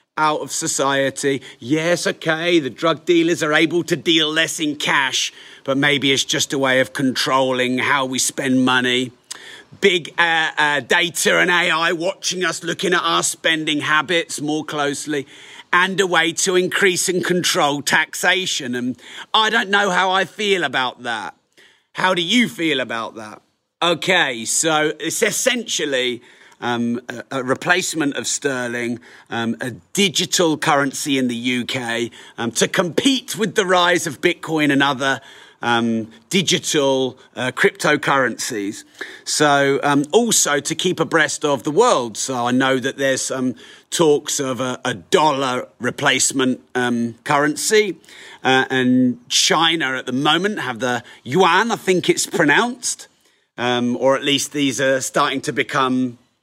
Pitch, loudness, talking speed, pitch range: 145 Hz, -18 LUFS, 150 wpm, 130-175 Hz